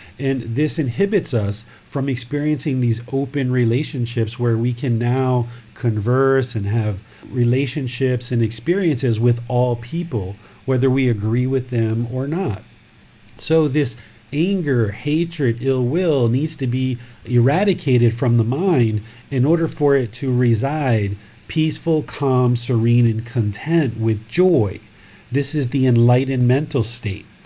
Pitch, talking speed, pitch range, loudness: 125 Hz, 135 wpm, 115-140 Hz, -19 LUFS